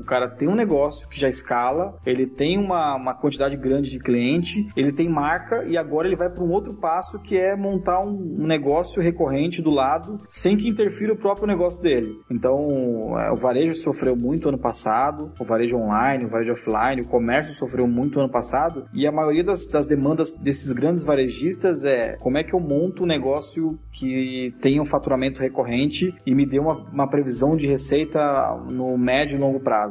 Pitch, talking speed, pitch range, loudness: 145 Hz, 195 wpm, 130-170 Hz, -22 LUFS